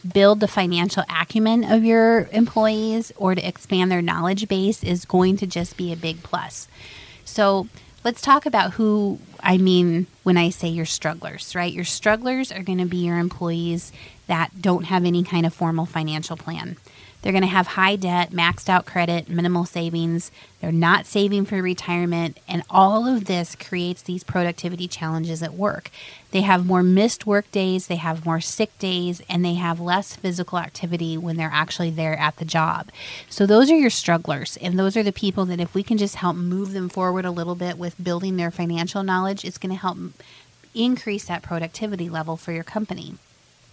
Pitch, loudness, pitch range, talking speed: 180 Hz, -22 LUFS, 170-195 Hz, 190 wpm